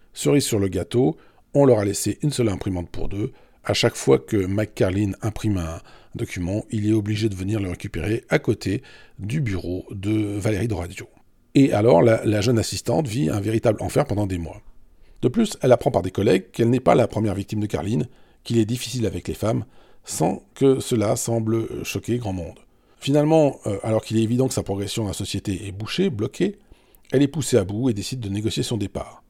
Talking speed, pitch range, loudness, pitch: 210 wpm, 100-120 Hz, -22 LUFS, 110 Hz